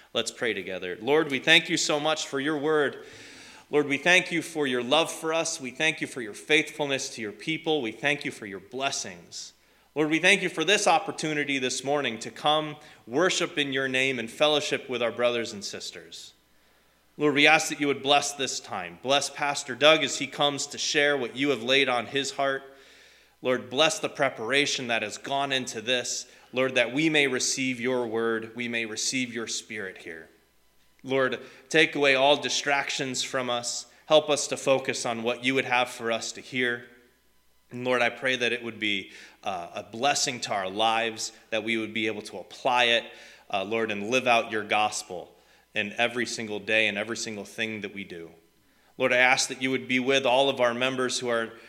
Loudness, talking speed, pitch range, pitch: -25 LUFS, 205 wpm, 115-145 Hz, 130 Hz